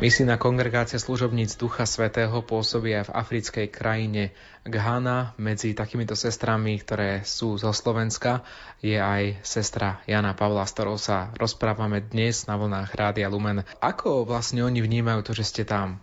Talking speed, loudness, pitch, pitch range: 145 wpm, -26 LUFS, 110 Hz, 105-115 Hz